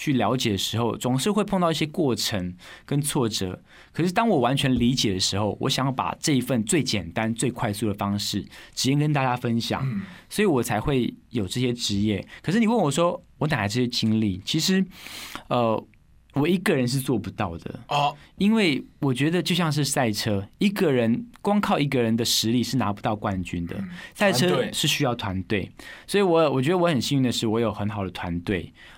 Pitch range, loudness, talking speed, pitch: 105-150 Hz, -24 LUFS, 295 characters per minute, 125 Hz